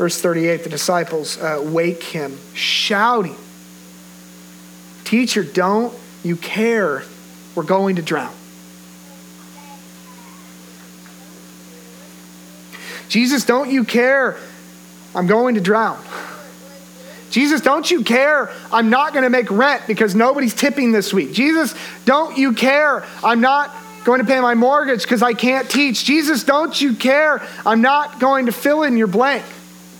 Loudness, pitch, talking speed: -16 LUFS, 210 Hz, 130 wpm